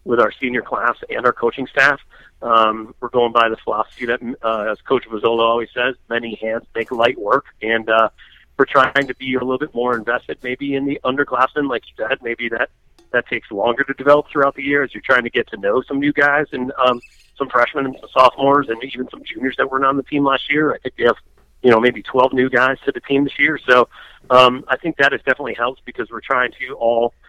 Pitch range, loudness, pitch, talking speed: 120-140 Hz, -18 LUFS, 130 Hz, 240 wpm